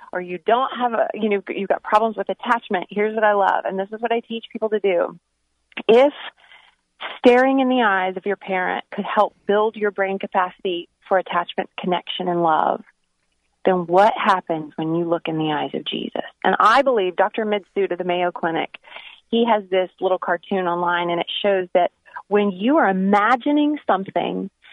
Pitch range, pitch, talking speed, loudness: 175-220 Hz, 195 Hz, 190 wpm, -20 LUFS